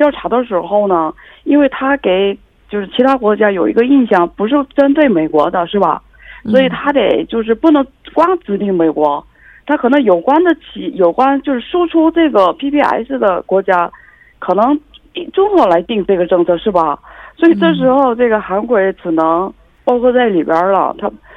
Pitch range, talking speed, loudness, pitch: 190-290 Hz, 265 characters per minute, -13 LUFS, 245 Hz